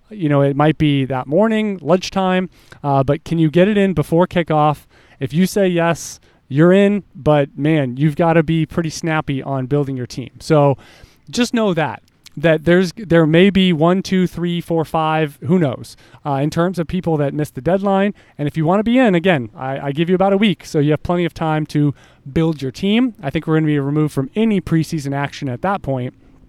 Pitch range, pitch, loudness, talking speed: 140-180 Hz, 160 Hz, -17 LUFS, 225 wpm